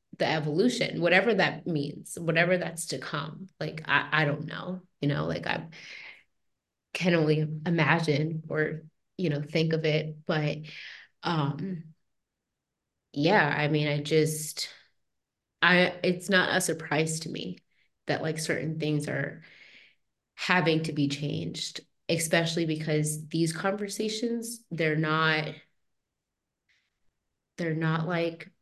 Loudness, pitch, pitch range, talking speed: -28 LUFS, 160 Hz, 155-175 Hz, 125 wpm